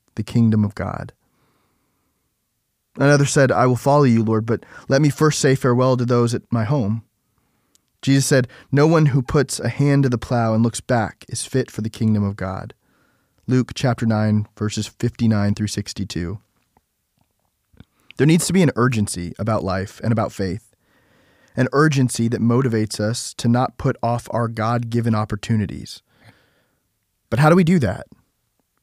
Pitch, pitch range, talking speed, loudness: 120 Hz, 110-130 Hz, 165 wpm, -19 LUFS